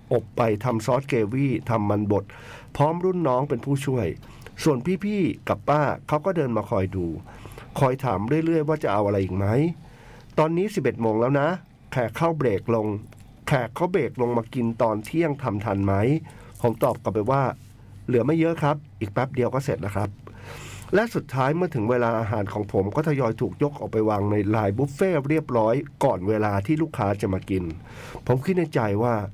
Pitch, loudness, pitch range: 120 Hz, -24 LUFS, 105-145 Hz